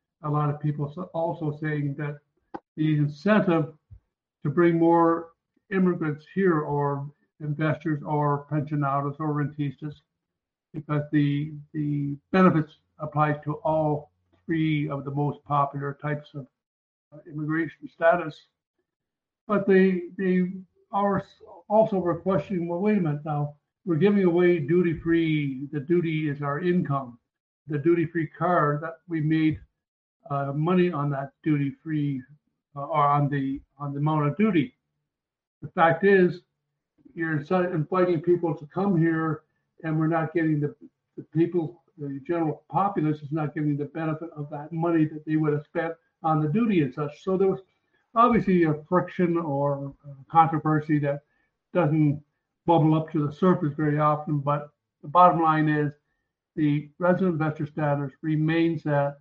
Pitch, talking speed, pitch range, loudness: 155 Hz, 145 wpm, 145-170 Hz, -25 LUFS